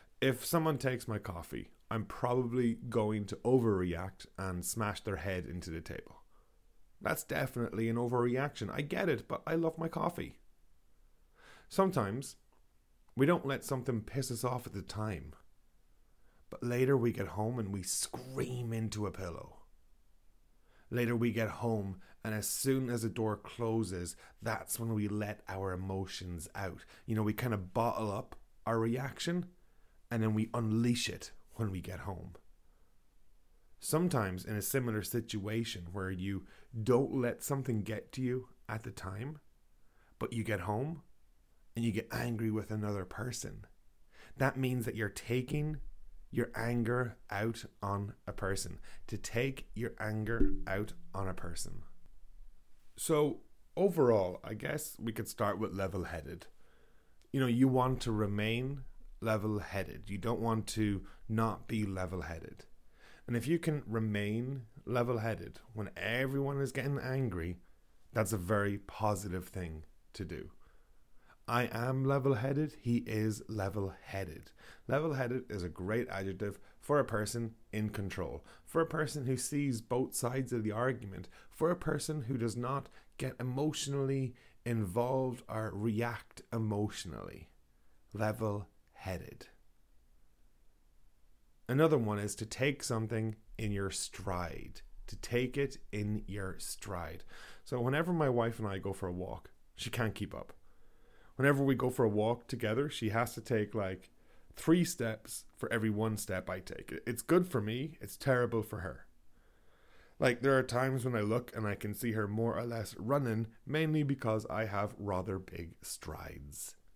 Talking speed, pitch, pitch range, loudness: 150 wpm, 110 Hz, 100-125 Hz, -36 LUFS